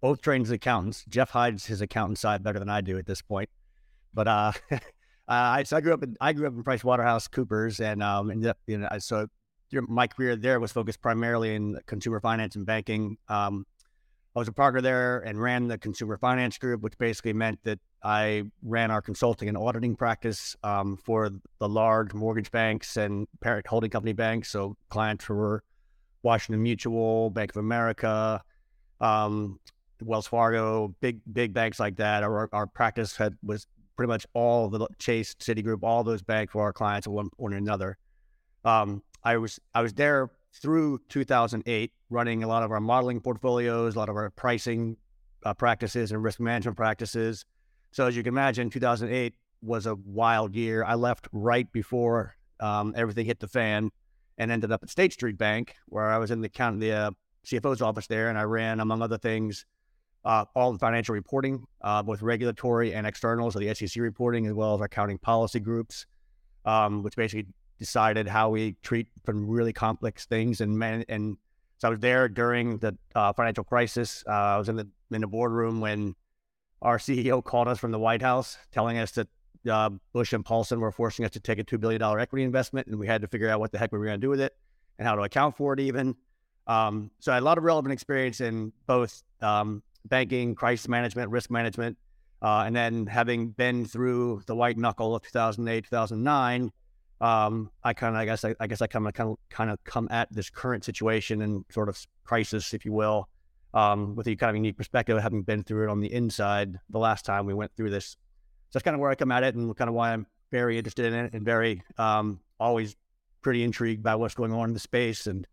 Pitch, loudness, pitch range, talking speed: 115 Hz, -28 LUFS, 105-120 Hz, 210 wpm